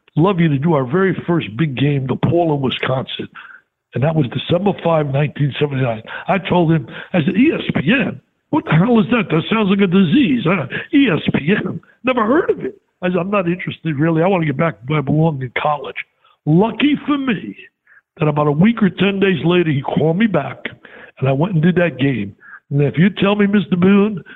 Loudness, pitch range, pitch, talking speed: -16 LUFS, 150-200 Hz, 170 Hz, 215 wpm